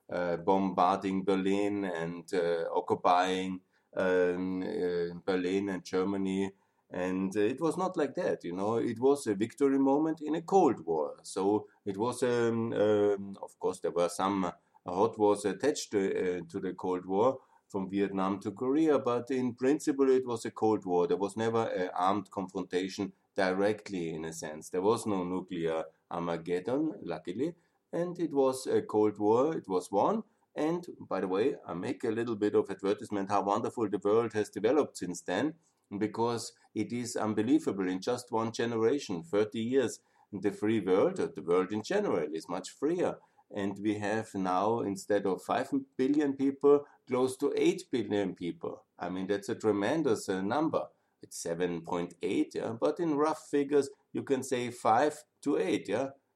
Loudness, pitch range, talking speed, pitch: -31 LUFS, 95-130 Hz, 170 wpm, 105 Hz